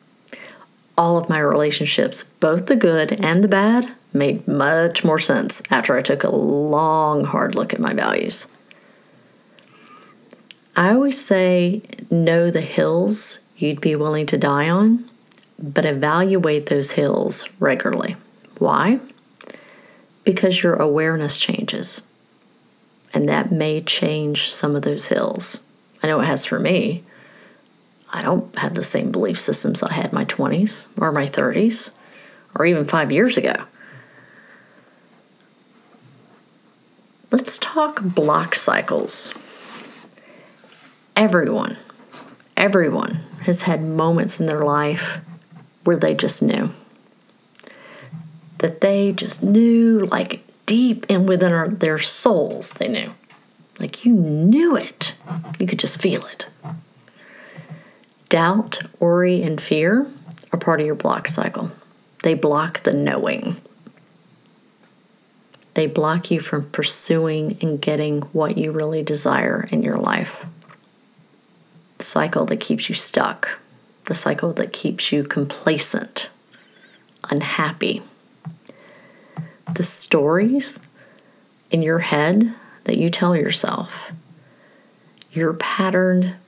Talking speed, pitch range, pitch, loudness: 120 wpm, 155-215 Hz, 175 Hz, -19 LUFS